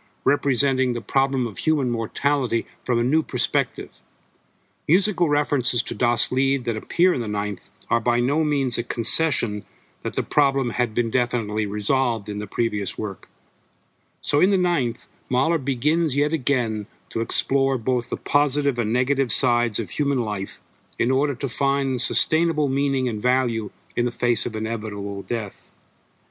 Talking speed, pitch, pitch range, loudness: 160 wpm, 125 Hz, 115-140 Hz, -23 LUFS